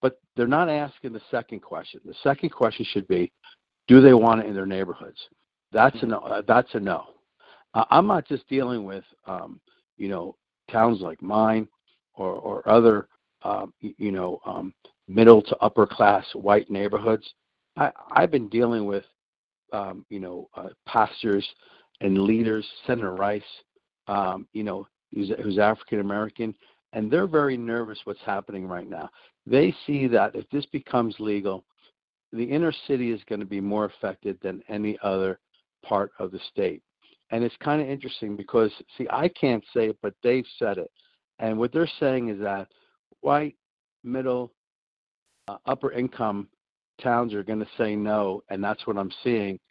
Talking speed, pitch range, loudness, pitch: 170 wpm, 100-130 Hz, -24 LUFS, 110 Hz